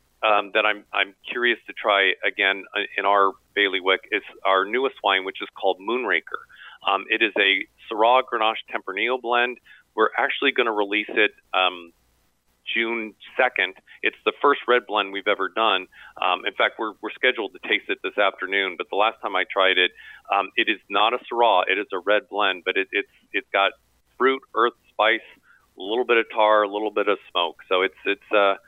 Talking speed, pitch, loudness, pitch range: 200 wpm, 105 Hz, -22 LUFS, 100-130 Hz